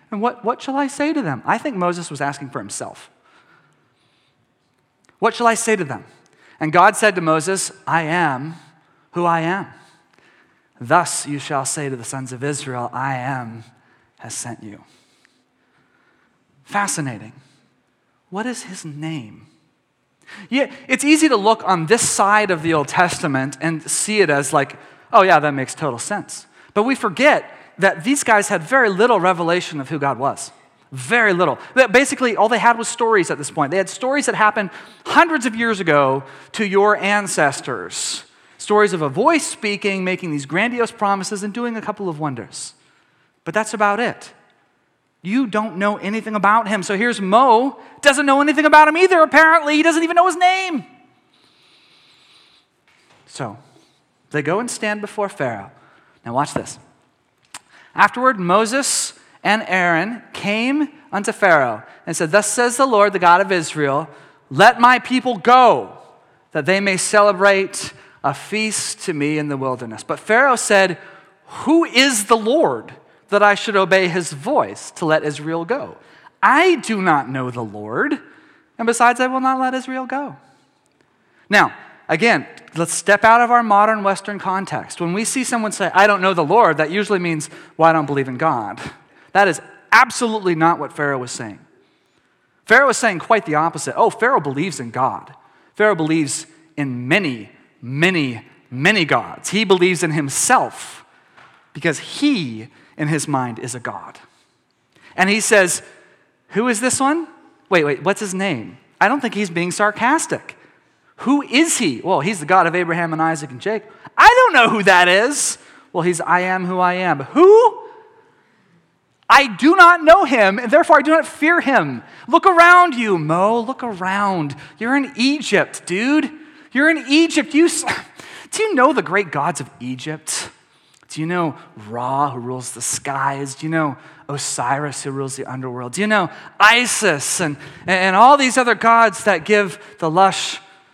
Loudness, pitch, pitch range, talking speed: -16 LUFS, 200 Hz, 155-240 Hz, 170 wpm